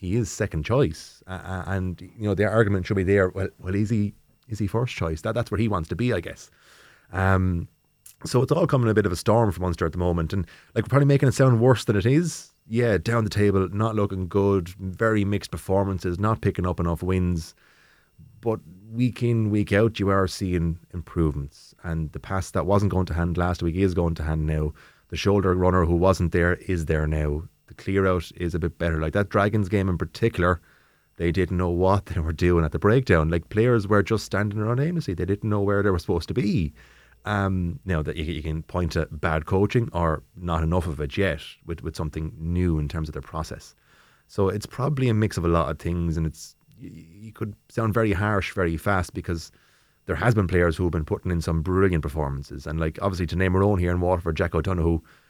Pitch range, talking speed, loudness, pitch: 85-105 Hz, 230 wpm, -24 LUFS, 95 Hz